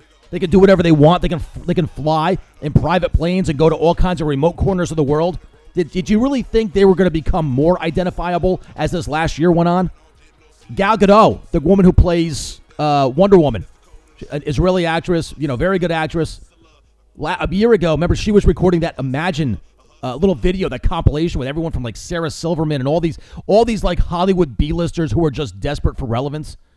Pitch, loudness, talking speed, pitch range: 165 Hz, -16 LUFS, 210 wpm, 150-185 Hz